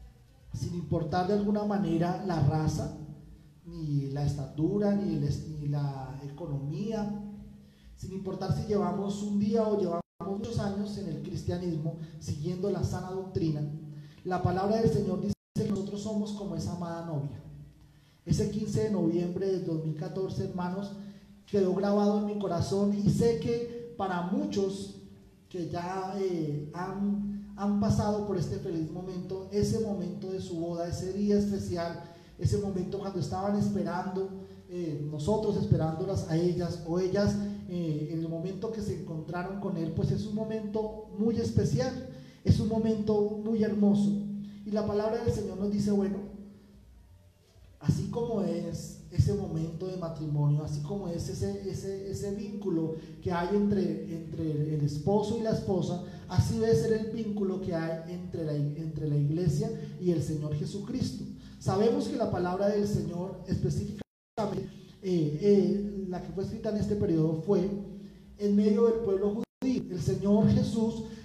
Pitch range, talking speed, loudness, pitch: 165-205 Hz, 155 wpm, -31 LUFS, 185 Hz